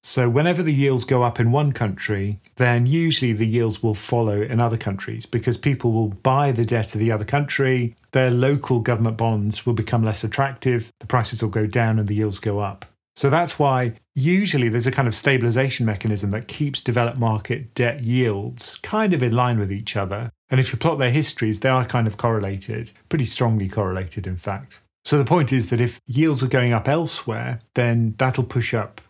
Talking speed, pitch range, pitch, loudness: 205 wpm, 110-130 Hz, 120 Hz, -21 LUFS